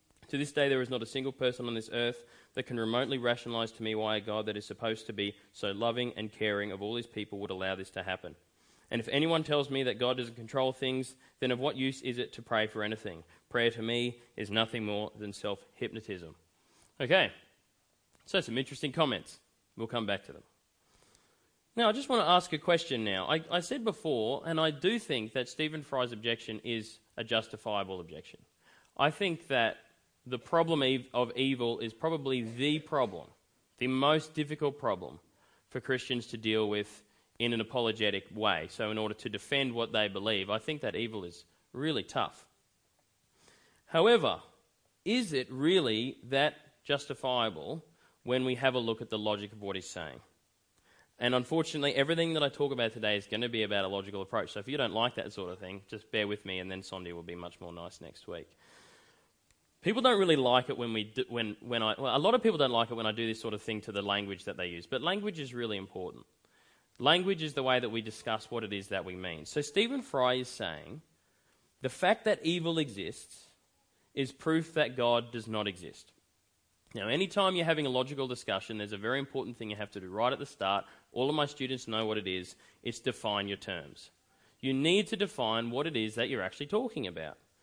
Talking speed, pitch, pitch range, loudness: 210 wpm, 120 Hz, 105-140 Hz, -33 LUFS